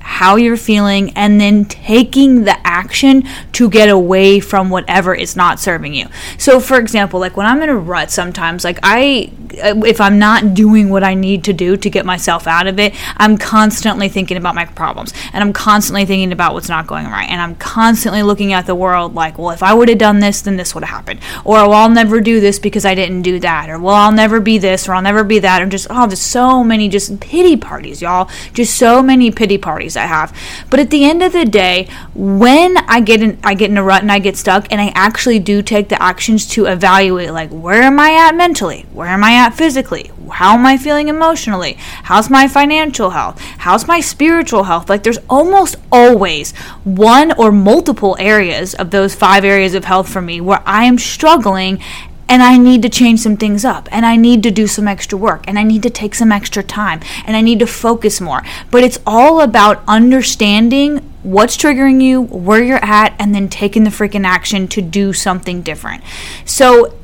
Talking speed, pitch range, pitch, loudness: 220 wpm, 190-235 Hz, 210 Hz, -10 LUFS